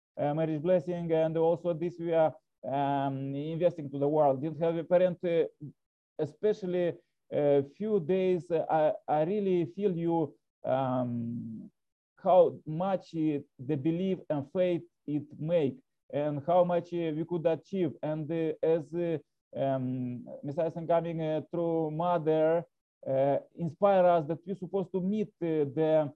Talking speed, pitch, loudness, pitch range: 150 wpm, 165 Hz, -30 LUFS, 150-175 Hz